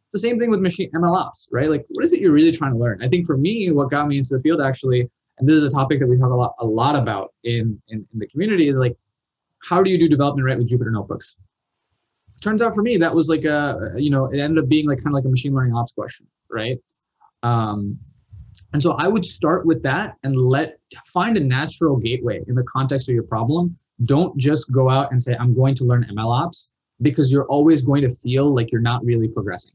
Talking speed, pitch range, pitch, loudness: 255 wpm, 120-155 Hz, 135 Hz, -19 LUFS